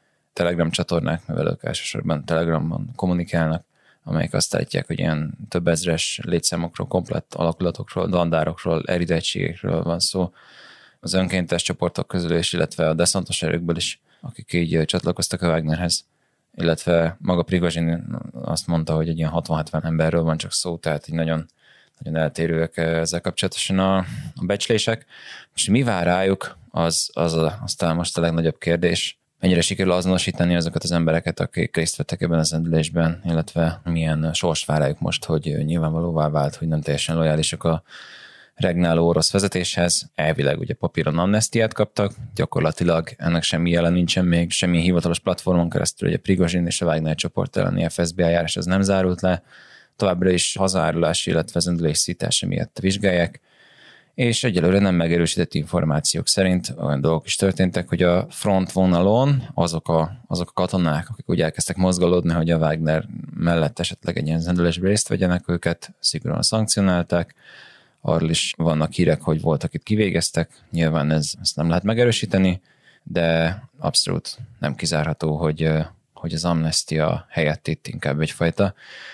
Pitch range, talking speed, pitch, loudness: 80-90 Hz, 150 wpm, 85 Hz, -21 LUFS